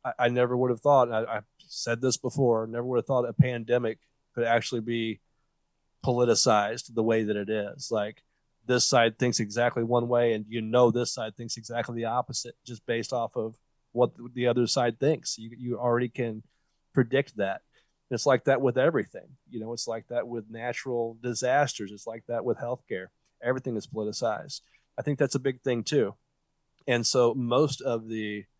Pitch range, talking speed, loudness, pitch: 115-125 Hz, 185 wpm, -27 LUFS, 120 Hz